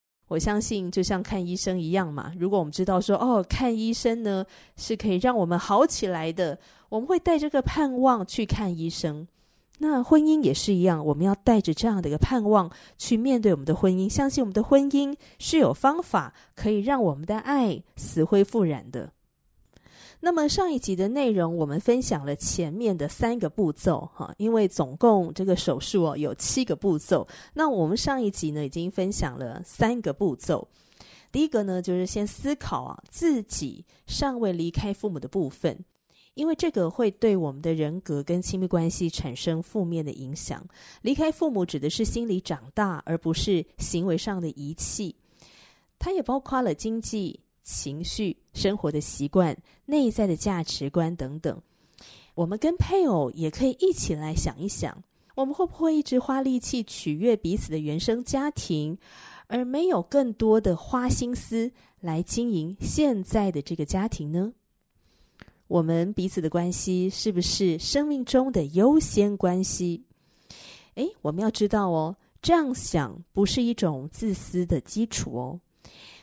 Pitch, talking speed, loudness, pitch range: 190 Hz, 255 characters per minute, -26 LUFS, 165-235 Hz